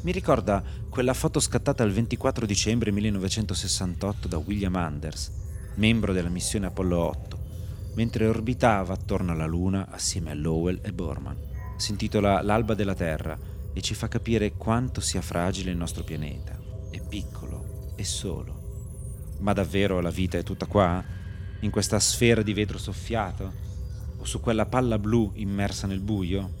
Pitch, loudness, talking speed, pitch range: 100 Hz, -27 LUFS, 150 wpm, 90-110 Hz